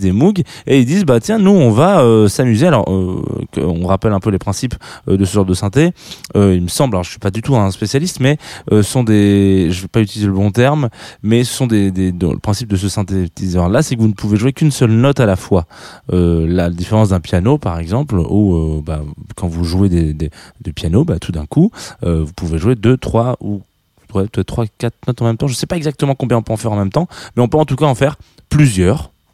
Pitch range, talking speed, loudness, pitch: 90-130 Hz, 270 wpm, -14 LUFS, 105 Hz